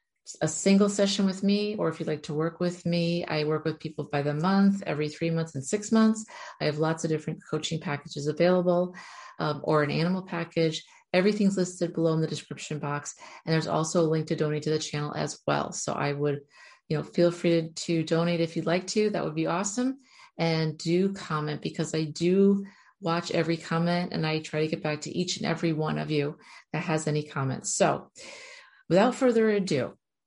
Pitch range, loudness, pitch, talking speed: 155-180 Hz, -28 LUFS, 165 Hz, 210 wpm